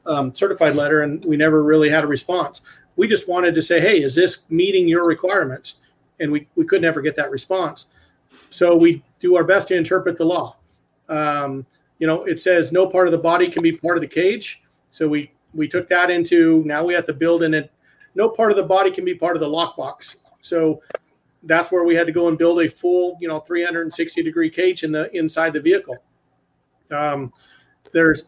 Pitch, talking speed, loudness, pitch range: 170 Hz, 215 wpm, -18 LUFS, 155-185 Hz